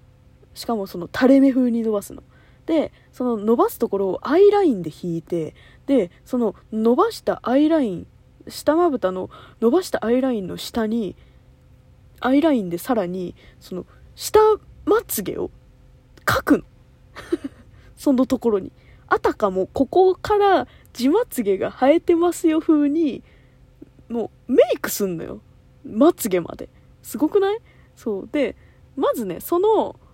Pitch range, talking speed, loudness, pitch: 220-335 Hz, 270 characters per minute, -20 LUFS, 260 Hz